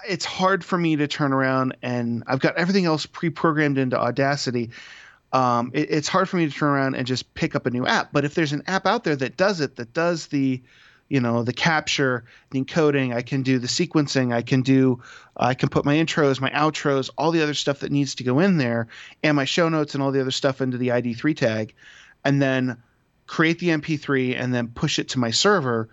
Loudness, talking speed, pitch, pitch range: -22 LUFS, 235 wpm, 140 Hz, 125-155 Hz